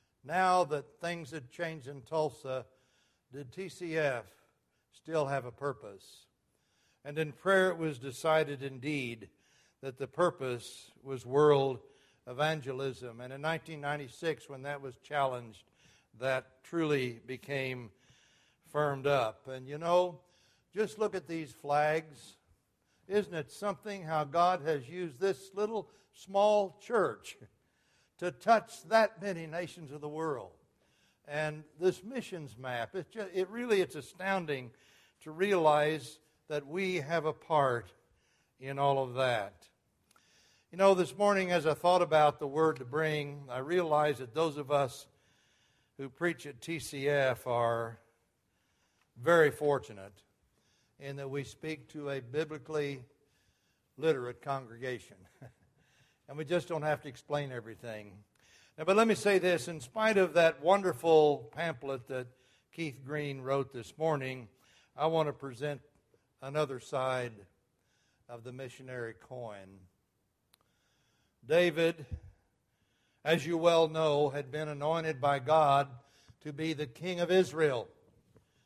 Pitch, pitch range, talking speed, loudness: 145 Hz, 130-165 Hz, 130 wpm, -32 LUFS